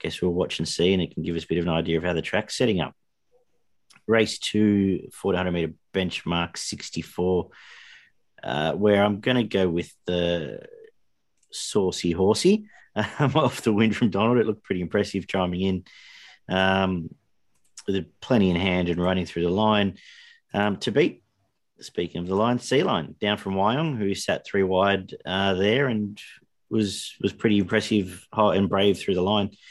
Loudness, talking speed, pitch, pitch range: -24 LUFS, 175 wpm, 100 Hz, 90-110 Hz